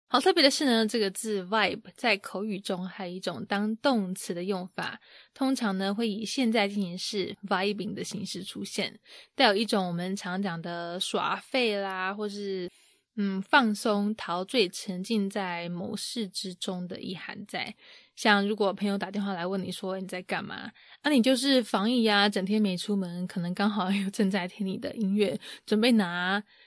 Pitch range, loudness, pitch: 190-215 Hz, -28 LUFS, 200 Hz